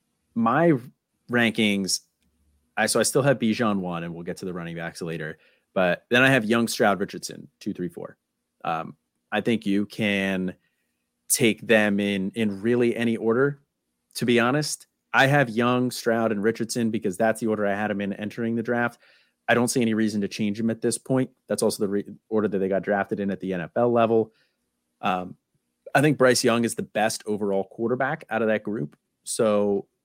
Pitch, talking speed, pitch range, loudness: 110 Hz, 200 wpm, 100-120 Hz, -24 LUFS